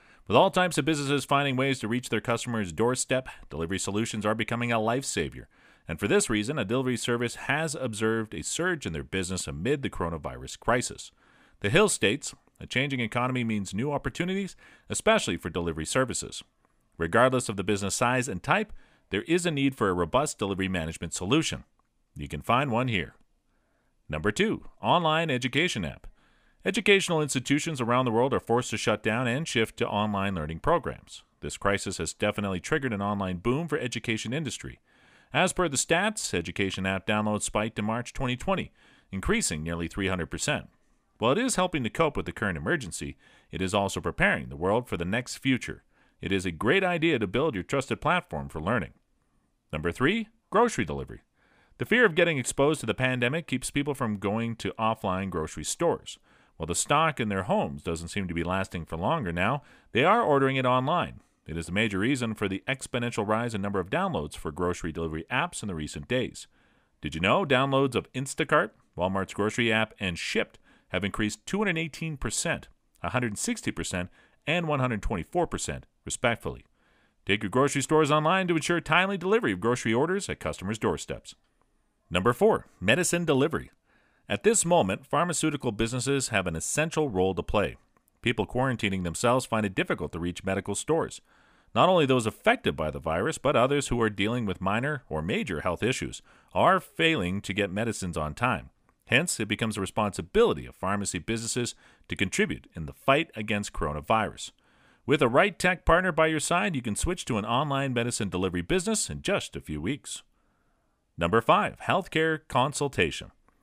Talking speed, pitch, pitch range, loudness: 175 wpm, 115 Hz, 95-140 Hz, -27 LUFS